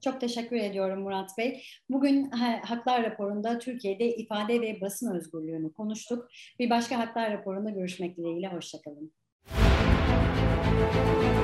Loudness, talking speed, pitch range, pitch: -29 LUFS, 110 wpm, 170-235 Hz, 210 Hz